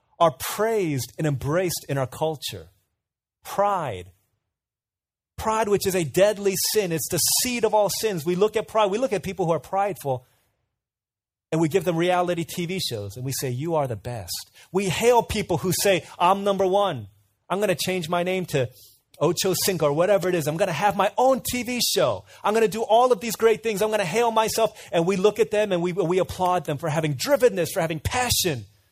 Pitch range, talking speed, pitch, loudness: 130-205 Hz, 215 wpm, 175 Hz, -23 LUFS